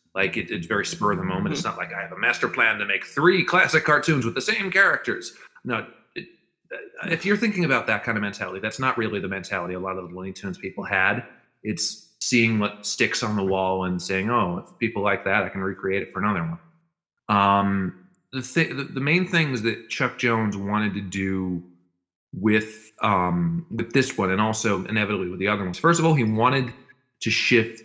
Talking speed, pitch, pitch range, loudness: 215 wpm, 110 Hz, 95-155 Hz, -23 LUFS